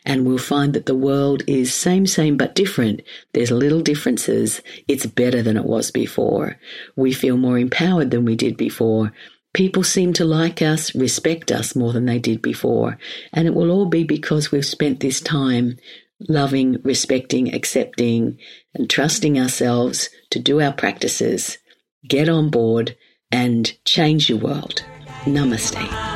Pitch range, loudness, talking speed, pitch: 120-155 Hz, -19 LUFS, 155 wpm, 135 Hz